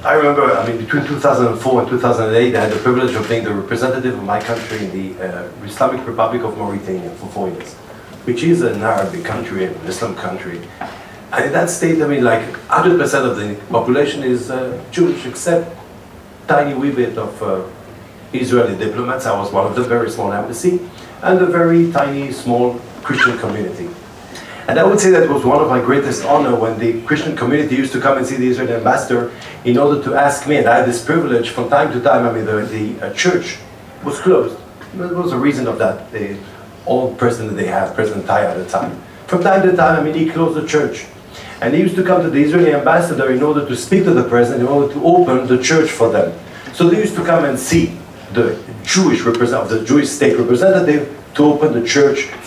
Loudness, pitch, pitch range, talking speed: -15 LUFS, 125 Hz, 115-150 Hz, 215 wpm